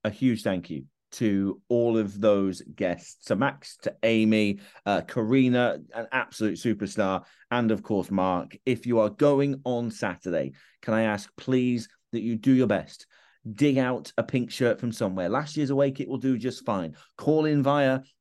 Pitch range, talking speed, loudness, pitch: 110-130 Hz, 180 wpm, -26 LUFS, 120 Hz